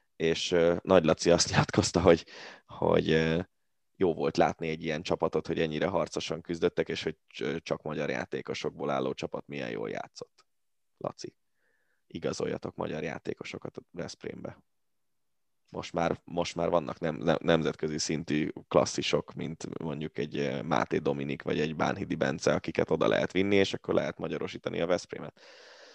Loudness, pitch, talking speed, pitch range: -30 LUFS, 80 Hz, 145 wpm, 75-90 Hz